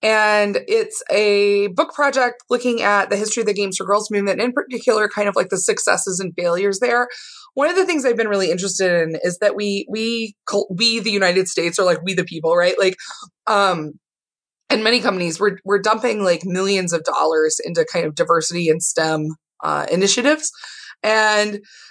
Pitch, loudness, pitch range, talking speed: 205 Hz, -18 LUFS, 185-240 Hz, 190 wpm